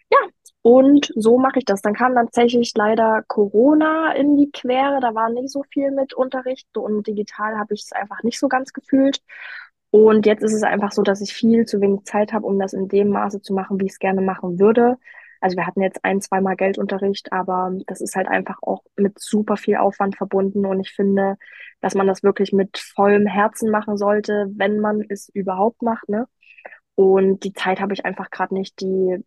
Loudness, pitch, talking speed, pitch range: -19 LUFS, 210 Hz, 210 wpm, 195-230 Hz